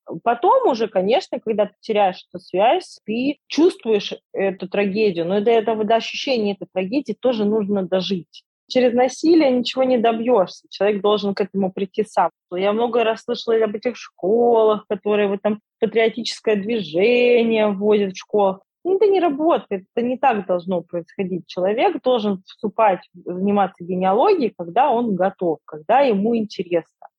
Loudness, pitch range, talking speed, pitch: -20 LUFS, 195-240 Hz, 150 wpm, 215 Hz